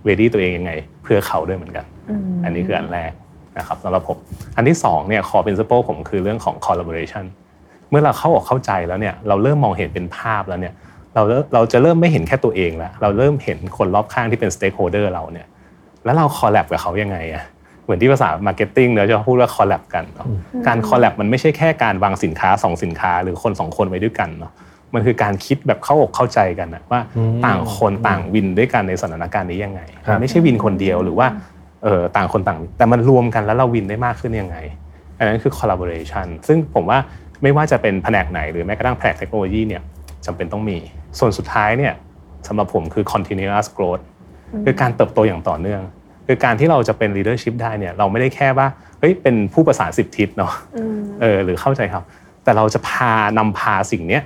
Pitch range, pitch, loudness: 90-125 Hz, 105 Hz, -17 LUFS